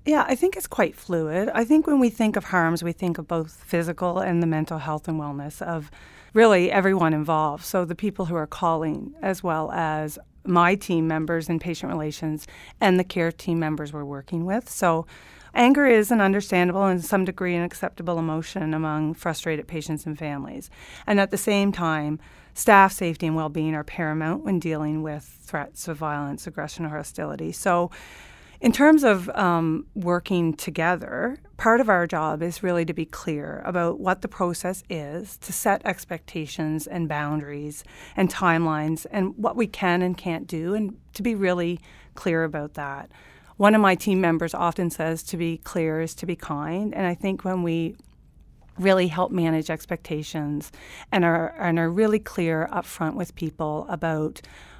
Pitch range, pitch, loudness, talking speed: 155-190 Hz, 170 Hz, -24 LUFS, 180 wpm